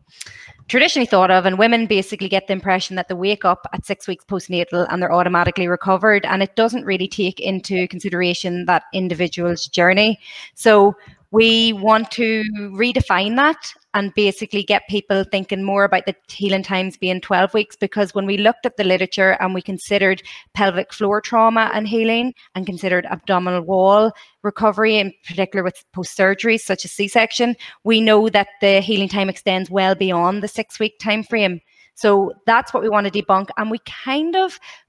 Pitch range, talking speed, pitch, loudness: 185-215 Hz, 175 wpm, 200 Hz, -17 LUFS